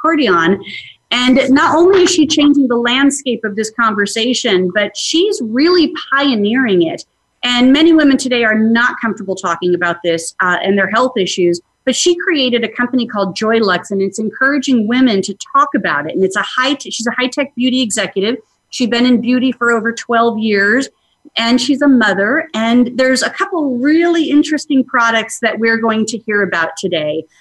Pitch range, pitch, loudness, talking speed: 205-270 Hz, 235 Hz, -13 LUFS, 180 wpm